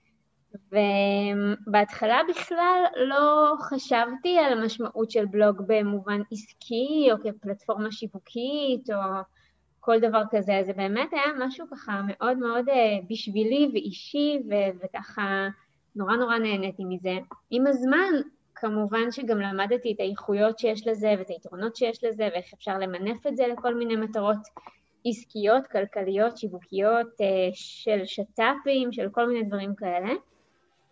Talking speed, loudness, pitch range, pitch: 120 wpm, -26 LUFS, 200-245 Hz, 220 Hz